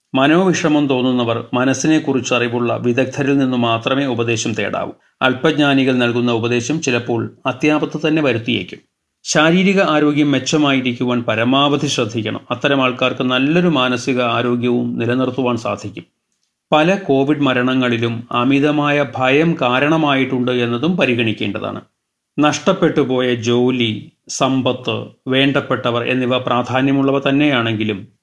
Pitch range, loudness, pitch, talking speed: 120-145 Hz, -16 LUFS, 130 Hz, 95 wpm